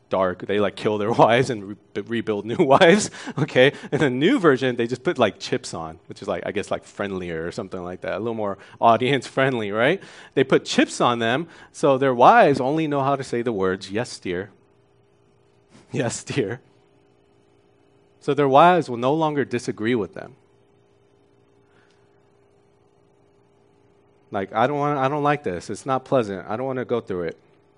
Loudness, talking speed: -21 LUFS, 185 wpm